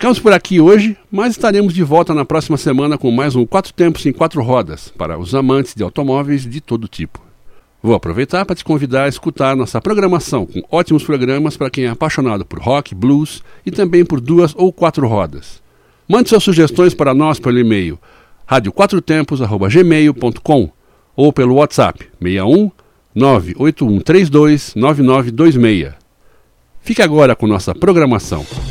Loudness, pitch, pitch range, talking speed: -13 LUFS, 145 Hz, 120-170 Hz, 145 wpm